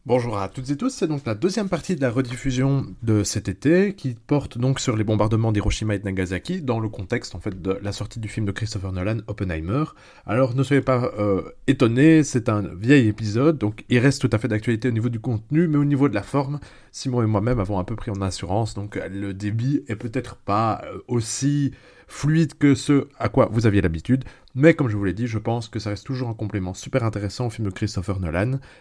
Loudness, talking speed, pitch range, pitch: -23 LUFS, 235 wpm, 105-135 Hz, 115 Hz